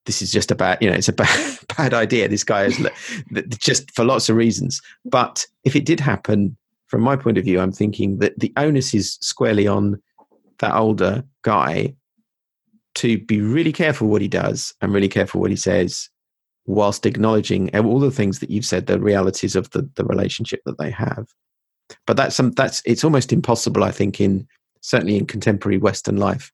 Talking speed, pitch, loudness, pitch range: 190 wpm, 110 Hz, -19 LUFS, 100-135 Hz